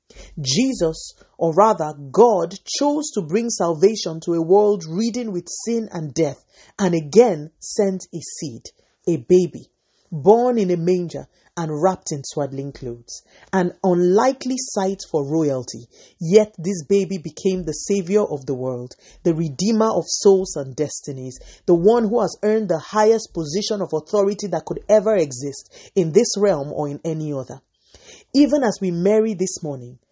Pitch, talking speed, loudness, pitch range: 180 Hz, 155 wpm, -20 LUFS, 155-210 Hz